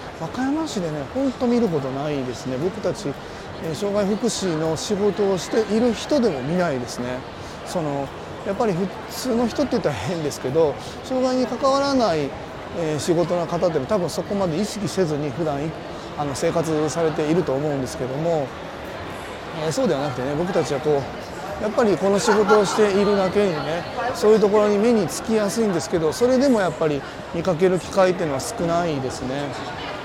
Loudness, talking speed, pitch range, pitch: -22 LUFS, 365 characters per minute, 155-215 Hz, 185 Hz